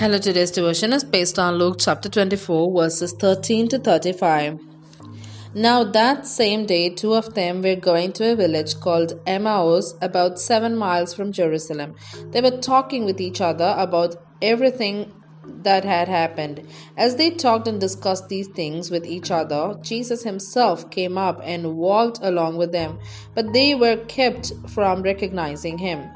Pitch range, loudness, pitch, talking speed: 170-220 Hz, -20 LUFS, 185 Hz, 160 wpm